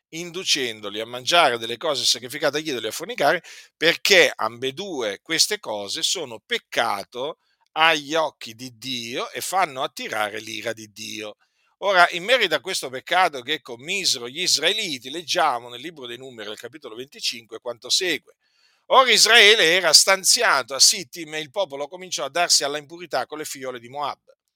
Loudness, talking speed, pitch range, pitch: -20 LUFS, 160 wpm, 120-180 Hz, 150 Hz